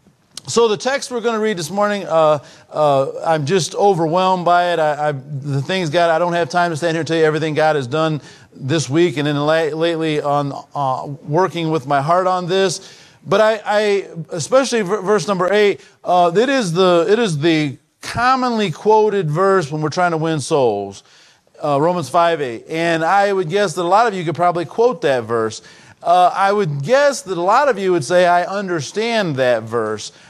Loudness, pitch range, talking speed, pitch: -17 LUFS, 155-195 Hz, 210 wpm, 175 Hz